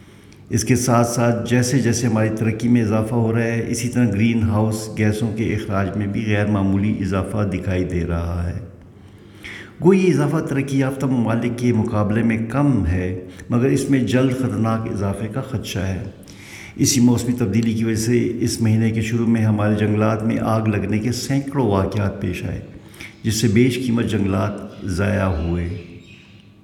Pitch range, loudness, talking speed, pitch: 100-120 Hz, -20 LUFS, 175 wpm, 110 Hz